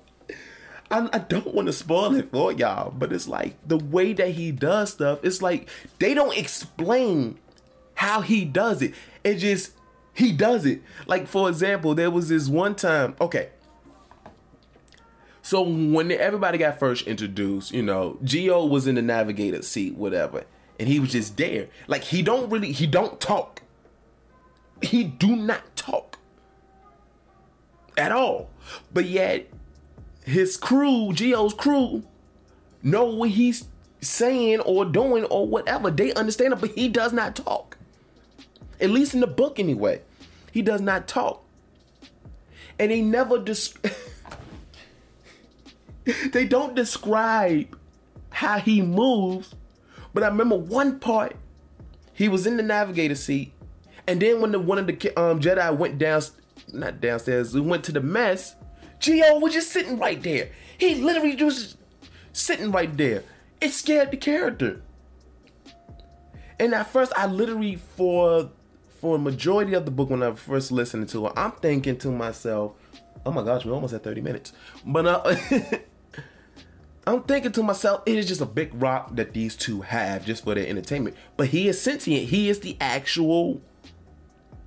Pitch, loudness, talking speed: 185 Hz, -23 LUFS, 155 wpm